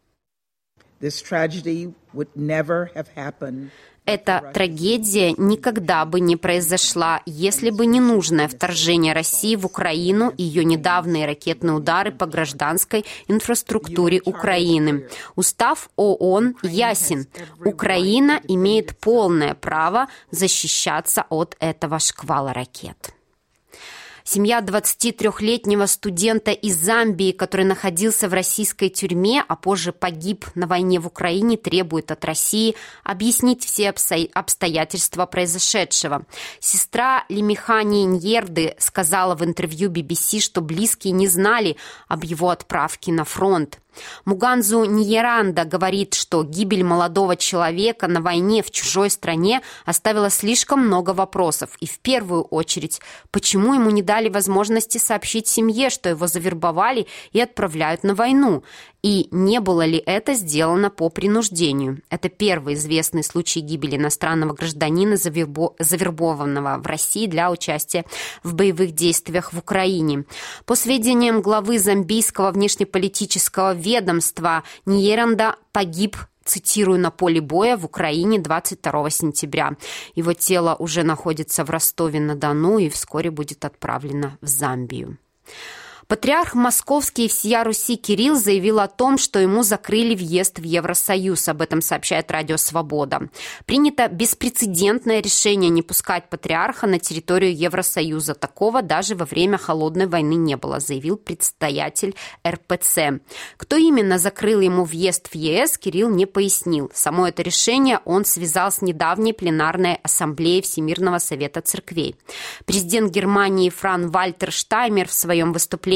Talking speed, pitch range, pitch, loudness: 120 wpm, 165-210 Hz, 185 Hz, -19 LUFS